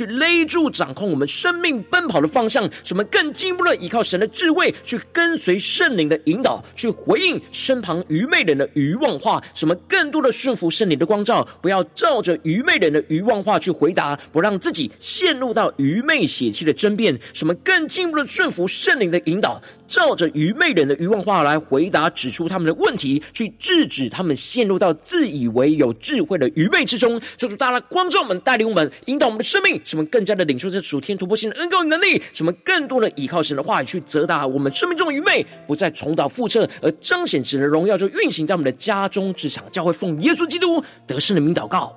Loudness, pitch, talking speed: -18 LUFS, 205 Hz, 335 characters per minute